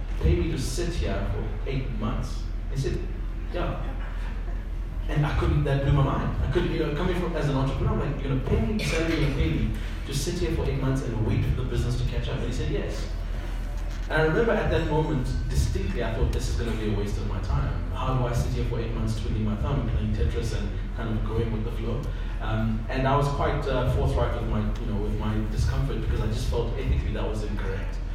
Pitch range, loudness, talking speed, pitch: 100-130 Hz, -28 LUFS, 250 wpm, 110 Hz